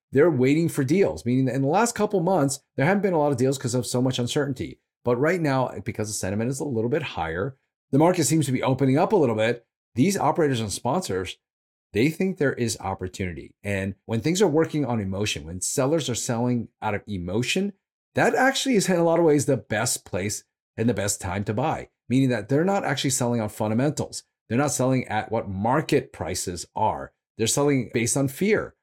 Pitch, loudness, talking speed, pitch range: 130 Hz, -24 LUFS, 220 wpm, 110-150 Hz